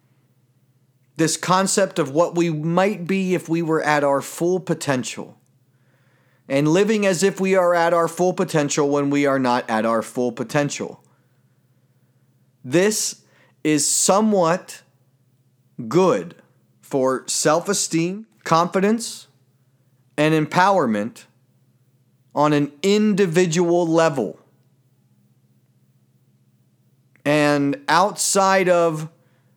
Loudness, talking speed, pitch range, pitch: -19 LUFS, 100 wpm, 130-175 Hz, 150 Hz